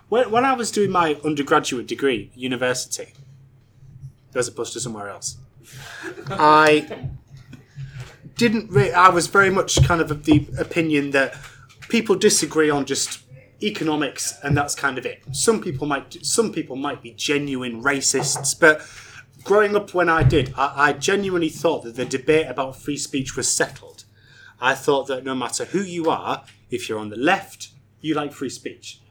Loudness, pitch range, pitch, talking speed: -20 LUFS, 130-160 Hz, 140 Hz, 170 wpm